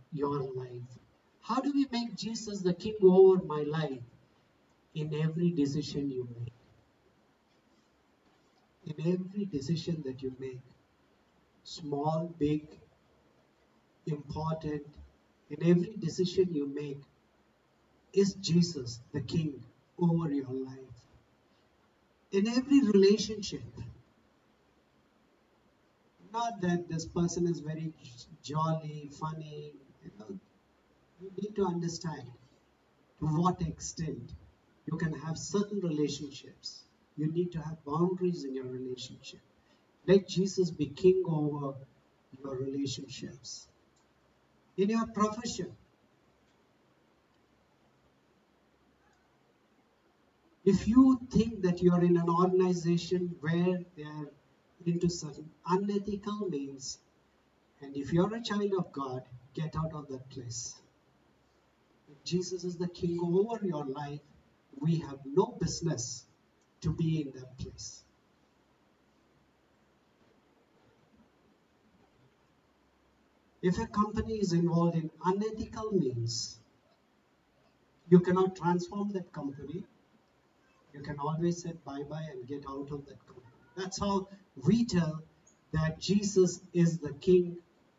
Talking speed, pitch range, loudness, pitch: 110 wpm, 140-185 Hz, -32 LUFS, 160 Hz